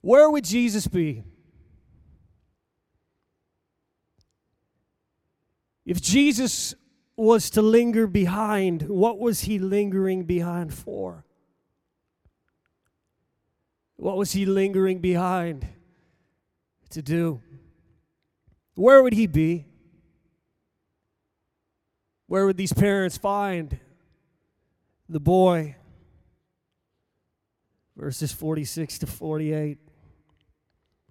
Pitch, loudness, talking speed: 175 Hz, -23 LUFS, 75 wpm